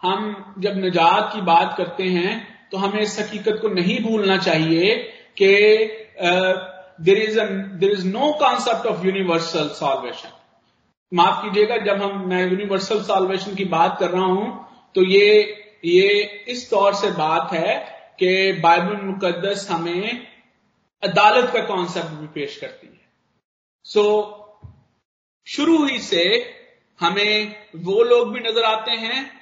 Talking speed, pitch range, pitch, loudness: 140 wpm, 185-225 Hz, 205 Hz, -19 LUFS